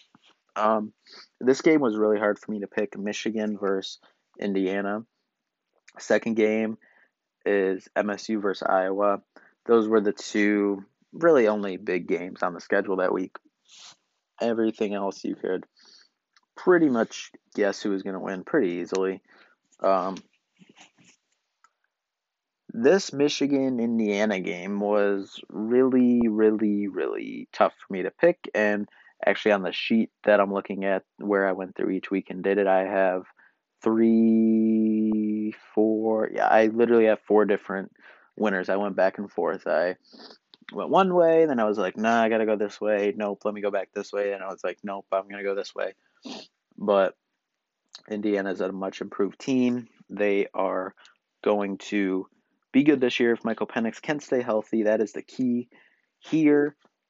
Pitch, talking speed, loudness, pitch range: 105 Hz, 160 wpm, -25 LUFS, 100-115 Hz